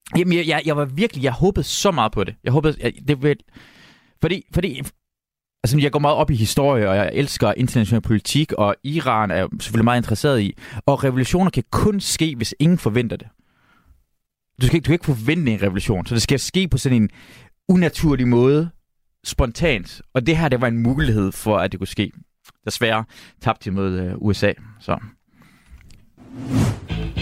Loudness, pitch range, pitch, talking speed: -20 LUFS, 105-150 Hz, 125 Hz, 185 wpm